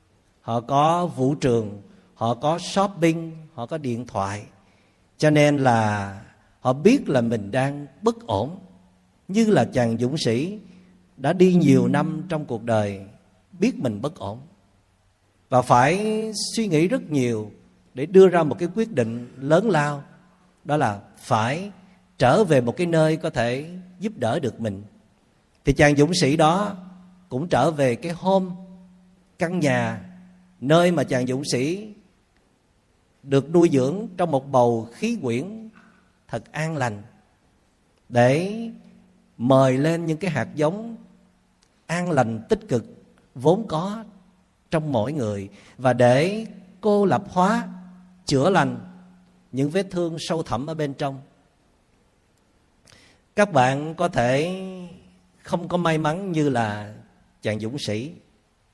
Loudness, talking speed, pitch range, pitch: -22 LUFS, 140 wpm, 115-180 Hz, 145 Hz